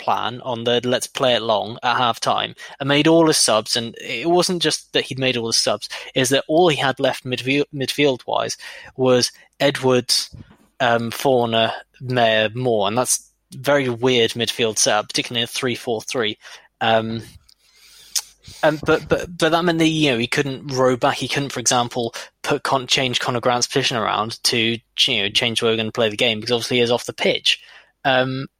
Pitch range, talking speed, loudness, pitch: 115-140 Hz, 190 wpm, -19 LUFS, 125 Hz